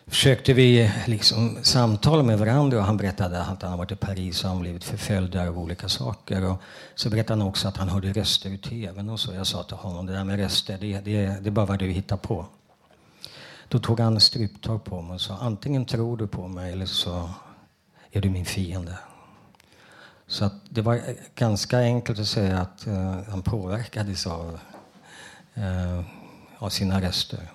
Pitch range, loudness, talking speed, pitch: 95-115 Hz, -25 LUFS, 190 wpm, 100 Hz